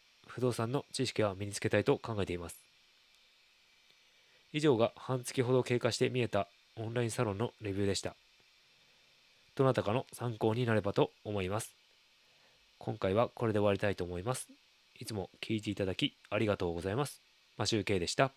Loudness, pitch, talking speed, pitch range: -34 LUFS, 110 Hz, 365 characters per minute, 100-130 Hz